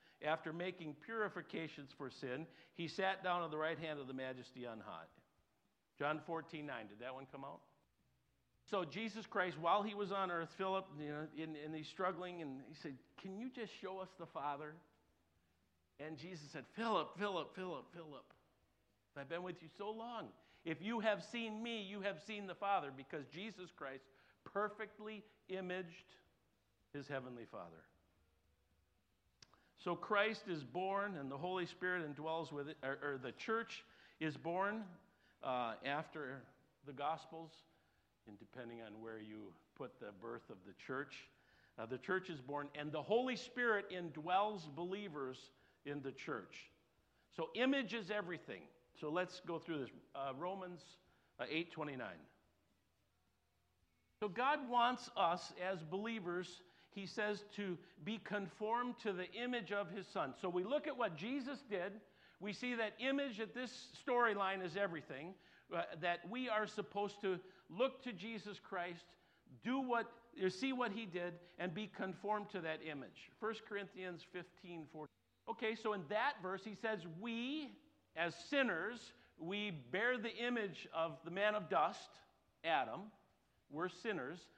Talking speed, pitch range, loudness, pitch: 155 wpm, 150-210 Hz, -44 LUFS, 180 Hz